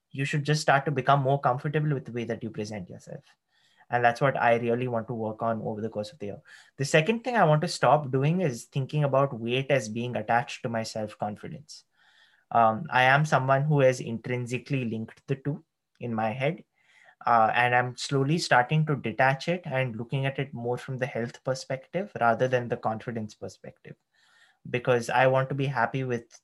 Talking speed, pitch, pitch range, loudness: 205 wpm, 130 Hz, 115-140 Hz, -27 LUFS